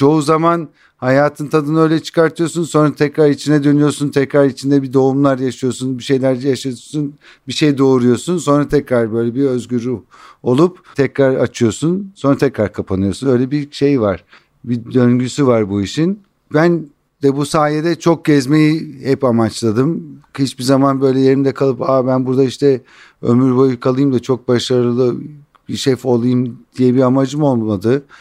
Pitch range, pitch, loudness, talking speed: 125-150 Hz, 135 Hz, -15 LUFS, 155 wpm